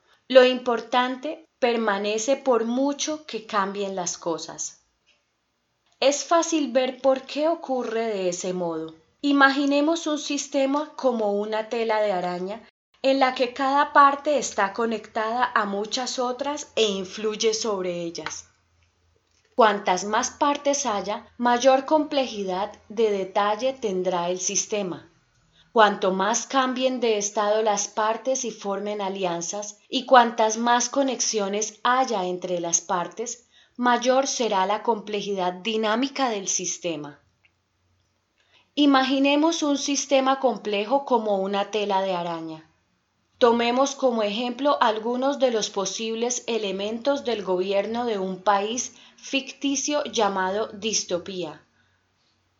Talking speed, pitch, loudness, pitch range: 115 wpm, 225 Hz, -24 LUFS, 195-260 Hz